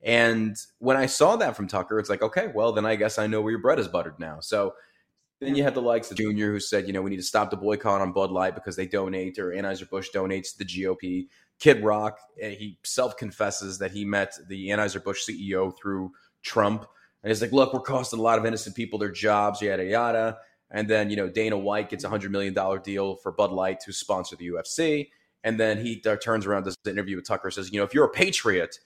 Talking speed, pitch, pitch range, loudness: 245 wpm, 105 Hz, 95-110 Hz, -26 LUFS